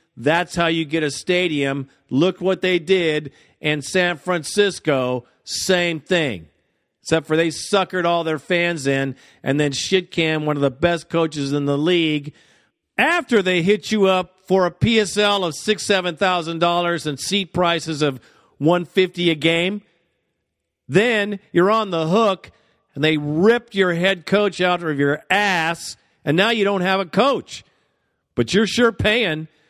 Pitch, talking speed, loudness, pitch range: 175 Hz, 165 wpm, -19 LUFS, 155-190 Hz